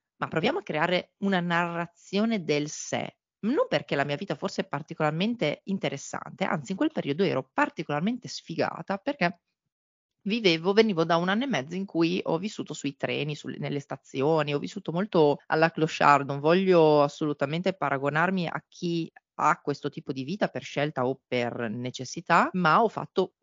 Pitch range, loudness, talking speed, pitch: 145-190 Hz, -27 LUFS, 165 wpm, 165 Hz